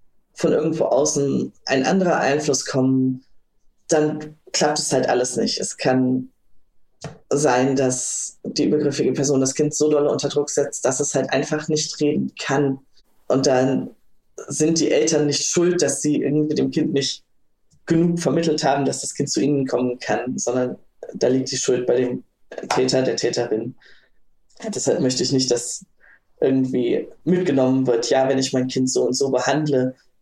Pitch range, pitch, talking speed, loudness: 130-150 Hz, 140 Hz, 165 wpm, -20 LUFS